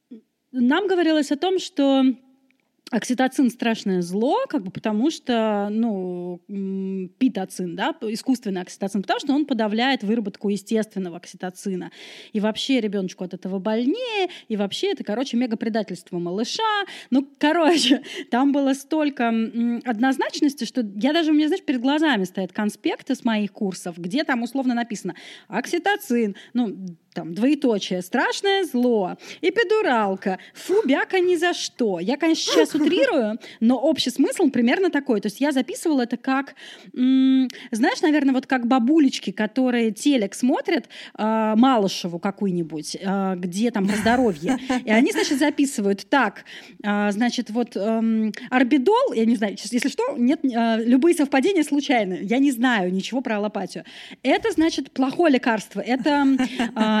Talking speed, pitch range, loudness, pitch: 140 wpm, 210-290 Hz, -22 LUFS, 245 Hz